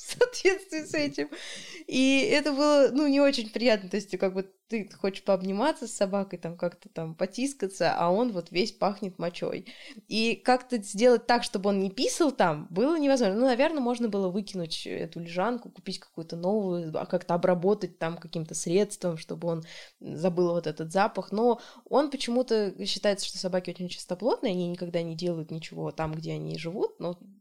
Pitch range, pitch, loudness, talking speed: 175-245 Hz, 195 Hz, -28 LUFS, 175 wpm